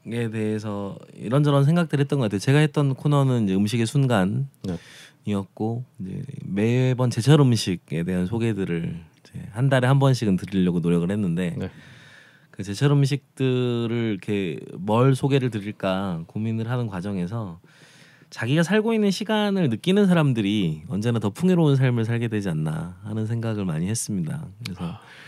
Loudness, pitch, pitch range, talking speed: -23 LUFS, 115 Hz, 100-140 Hz, 335 characters per minute